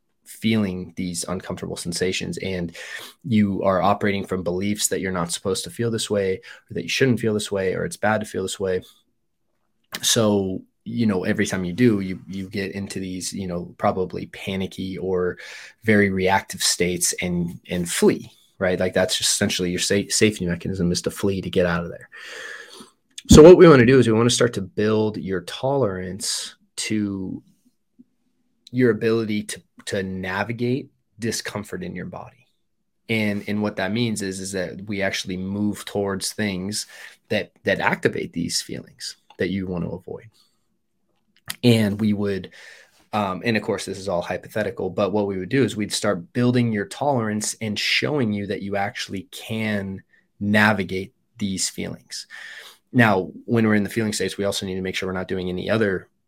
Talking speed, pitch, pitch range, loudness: 180 wpm, 100 Hz, 95-110 Hz, -22 LUFS